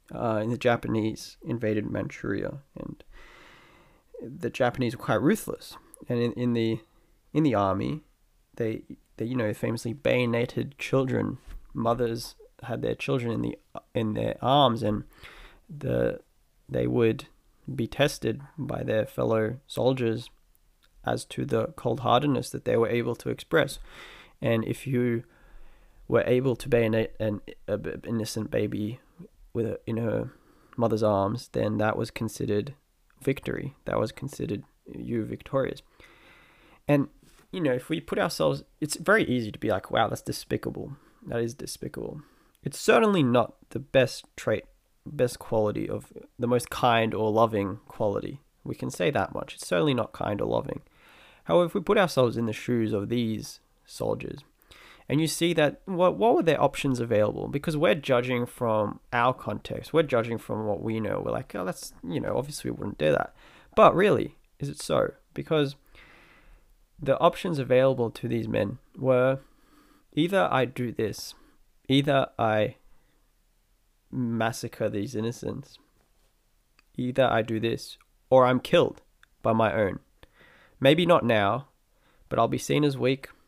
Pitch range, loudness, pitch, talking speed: 110-135 Hz, -27 LUFS, 120 Hz, 150 wpm